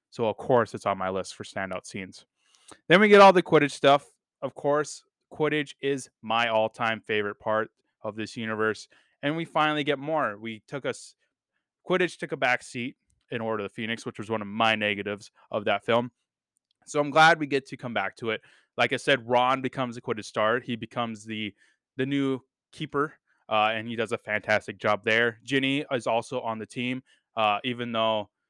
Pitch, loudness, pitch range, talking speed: 120 Hz, -26 LUFS, 110-140 Hz, 200 wpm